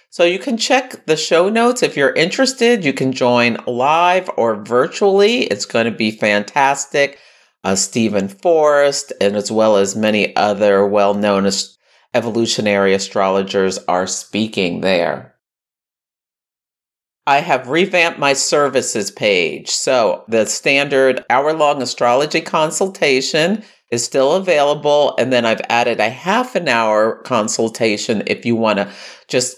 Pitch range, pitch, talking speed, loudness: 105-155 Hz, 120 Hz, 140 wpm, -15 LUFS